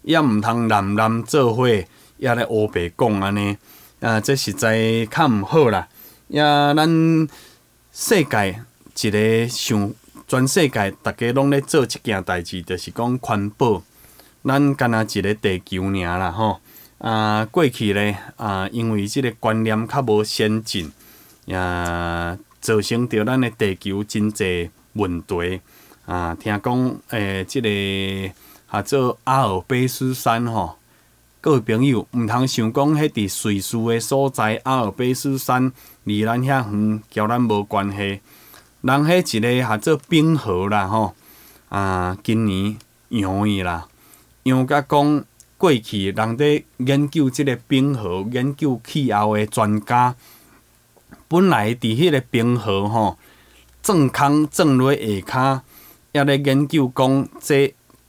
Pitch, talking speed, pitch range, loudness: 110 Hz, 190 characters per minute, 100-130 Hz, -20 LUFS